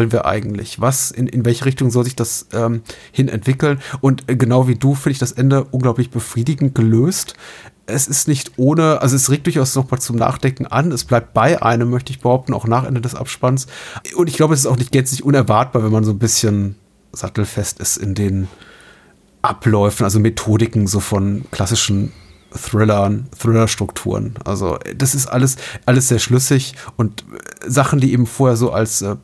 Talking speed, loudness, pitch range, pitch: 185 wpm, -16 LUFS, 110-135 Hz, 125 Hz